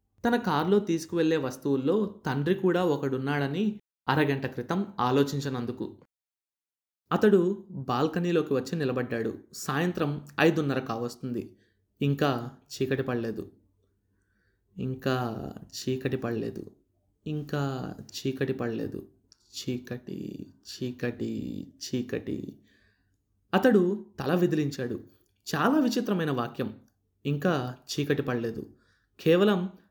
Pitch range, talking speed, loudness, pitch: 120-165 Hz, 80 wpm, -29 LUFS, 135 Hz